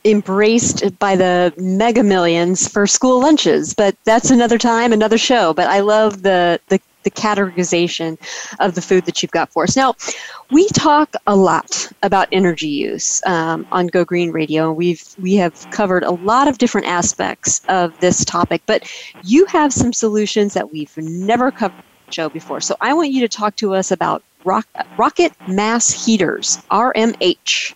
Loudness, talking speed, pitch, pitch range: -15 LUFS, 170 wpm, 200 Hz, 180-230 Hz